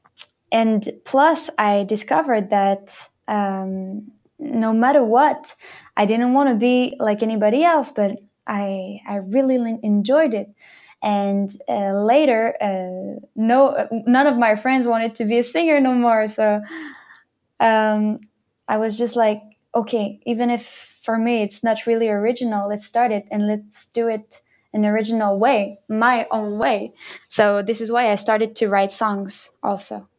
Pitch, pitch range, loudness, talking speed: 220 Hz, 205-240 Hz, -19 LUFS, 155 wpm